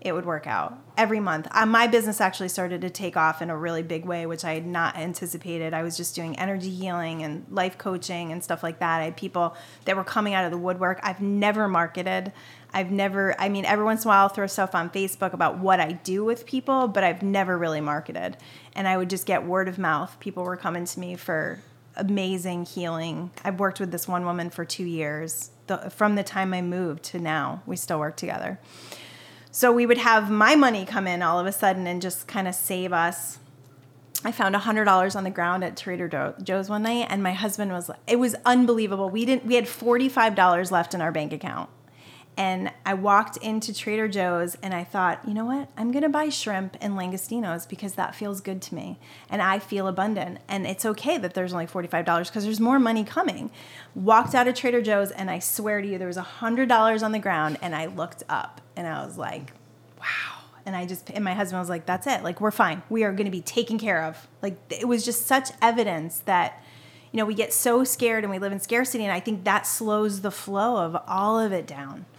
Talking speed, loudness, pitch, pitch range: 230 wpm, -25 LUFS, 190 Hz, 175-215 Hz